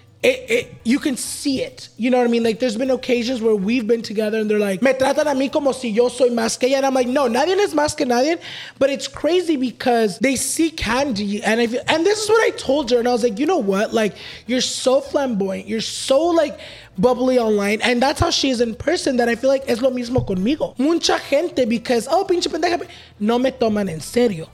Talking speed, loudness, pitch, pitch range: 245 wpm, -19 LUFS, 255 Hz, 235-290 Hz